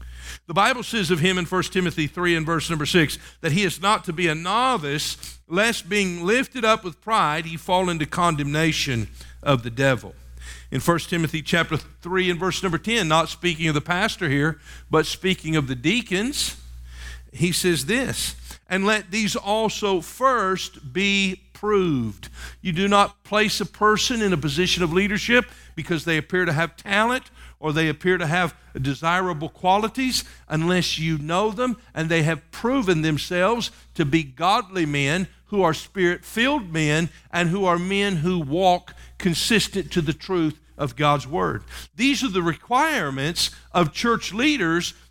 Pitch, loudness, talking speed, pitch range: 175 Hz, -22 LUFS, 170 wpm, 155-200 Hz